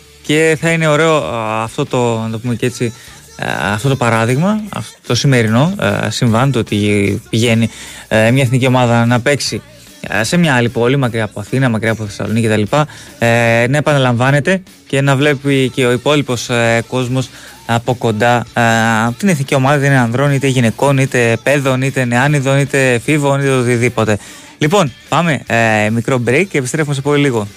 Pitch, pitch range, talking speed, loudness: 125 Hz, 115-140 Hz, 165 wpm, -13 LUFS